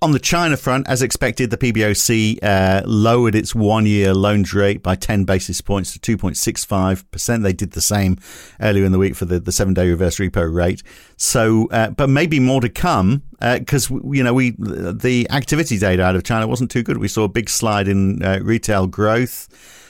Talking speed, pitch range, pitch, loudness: 195 wpm, 95-120 Hz, 105 Hz, -17 LUFS